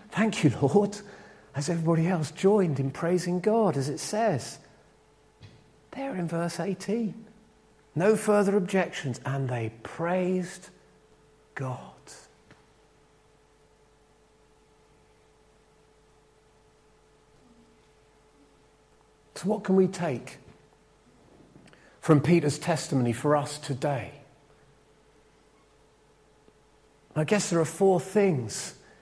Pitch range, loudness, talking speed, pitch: 145-190 Hz, -27 LUFS, 85 wpm, 160 Hz